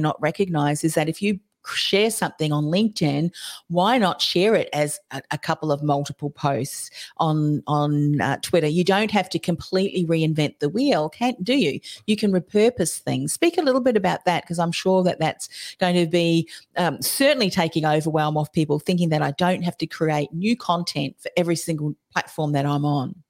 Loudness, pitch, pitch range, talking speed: -22 LUFS, 165 Hz, 150-190 Hz, 195 wpm